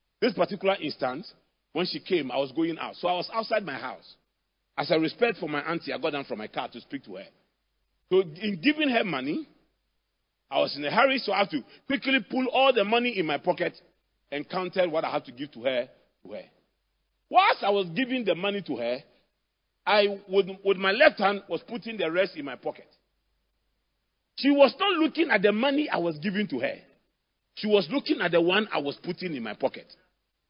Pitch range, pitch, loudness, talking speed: 175-265 Hz, 200 Hz, -26 LUFS, 215 wpm